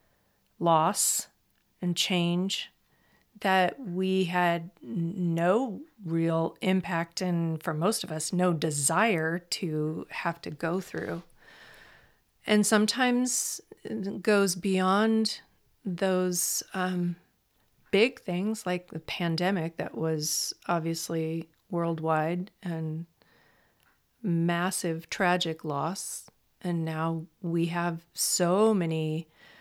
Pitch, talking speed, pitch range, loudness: 175 Hz, 95 wpm, 165-190 Hz, -28 LUFS